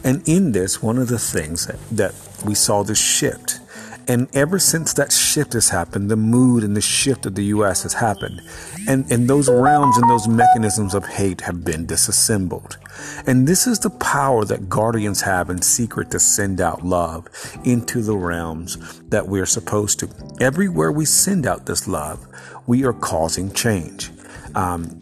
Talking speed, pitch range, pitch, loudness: 175 wpm, 90-125 Hz, 110 Hz, -18 LUFS